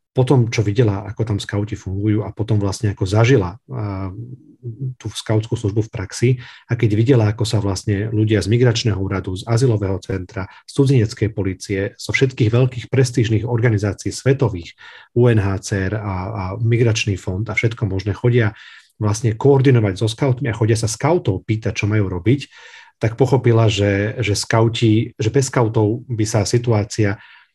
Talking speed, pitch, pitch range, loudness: 155 wpm, 110 Hz, 100-120 Hz, -18 LUFS